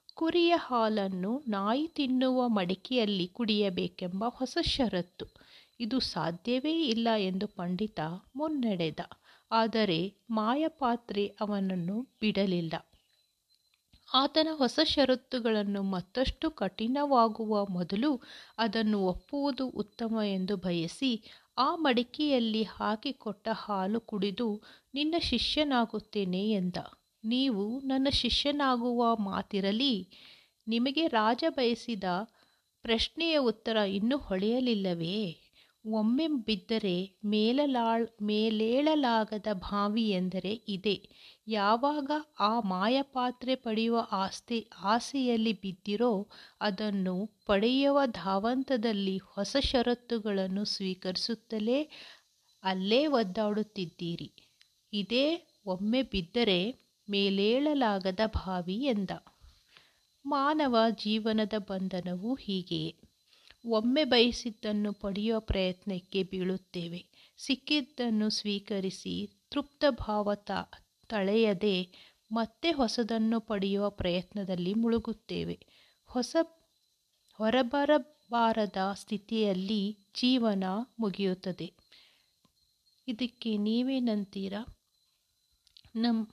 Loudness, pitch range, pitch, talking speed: -31 LUFS, 200-250 Hz, 220 Hz, 70 wpm